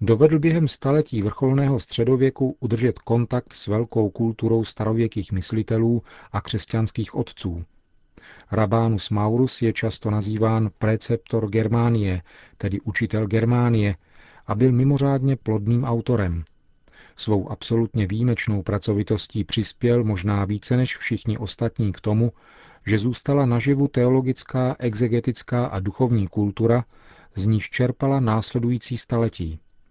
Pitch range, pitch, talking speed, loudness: 105-125 Hz, 115 Hz, 110 wpm, -22 LUFS